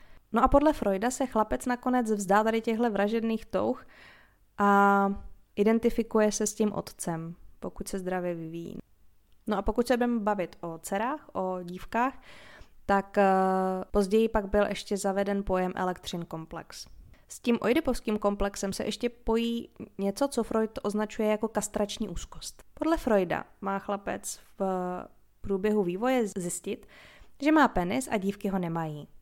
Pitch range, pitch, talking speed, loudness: 195-230 Hz, 205 Hz, 145 wpm, -29 LUFS